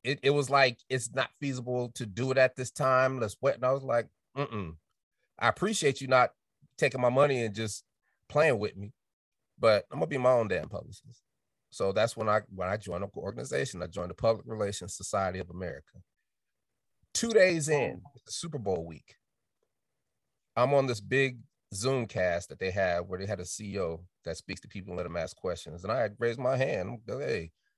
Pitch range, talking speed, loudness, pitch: 100-135 Hz, 205 wpm, -30 LUFS, 120 Hz